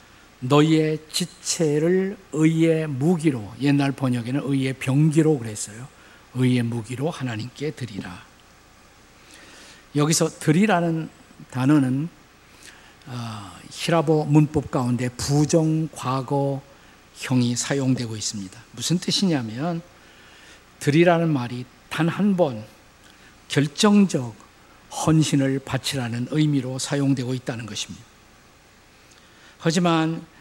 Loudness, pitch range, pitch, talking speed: -22 LUFS, 125-160 Hz, 140 Hz, 220 characters per minute